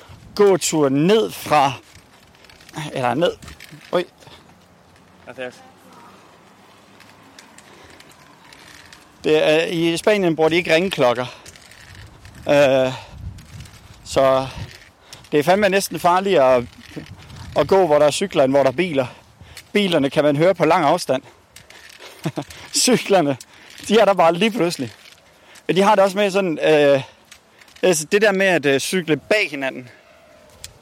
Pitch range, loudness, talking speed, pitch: 130-190 Hz, -18 LUFS, 120 wpm, 150 Hz